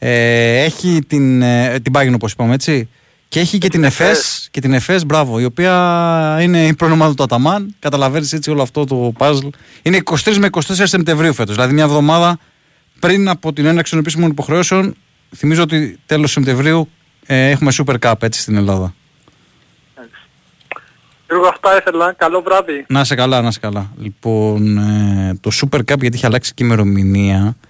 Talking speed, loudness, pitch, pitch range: 155 wpm, -13 LUFS, 145 Hz, 120-165 Hz